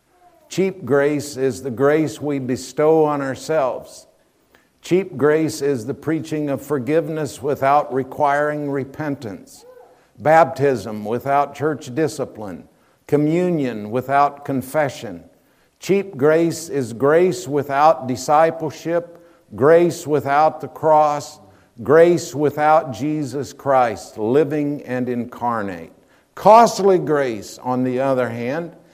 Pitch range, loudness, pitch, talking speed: 135-160 Hz, -19 LUFS, 145 Hz, 100 wpm